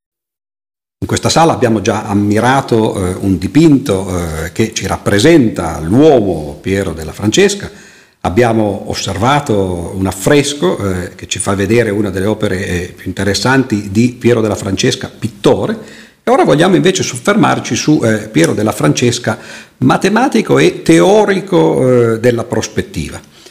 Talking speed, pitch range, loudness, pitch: 135 wpm, 95-125 Hz, -12 LUFS, 110 Hz